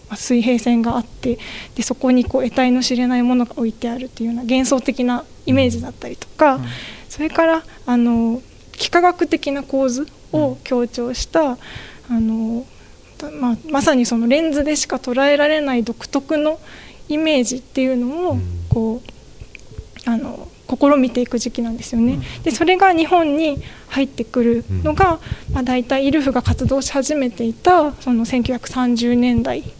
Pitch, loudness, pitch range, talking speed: 255 Hz, -18 LUFS, 240-295 Hz, 305 characters per minute